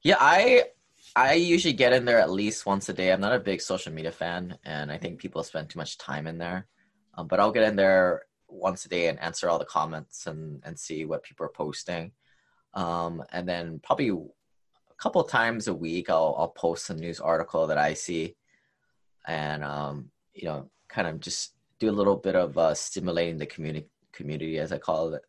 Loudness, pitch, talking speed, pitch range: -27 LUFS, 85 Hz, 210 wpm, 80-100 Hz